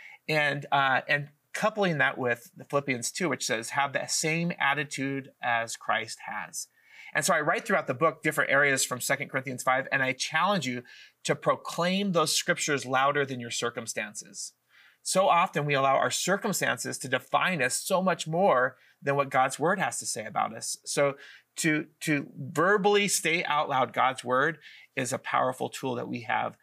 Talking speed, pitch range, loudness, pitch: 180 wpm, 130-170 Hz, -27 LUFS, 145 Hz